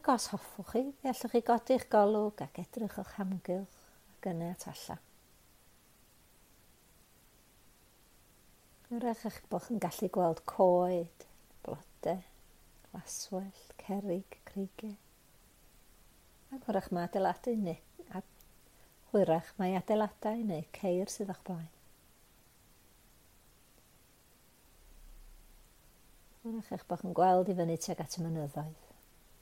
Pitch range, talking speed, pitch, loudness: 175-220 Hz, 105 wpm, 195 Hz, -35 LUFS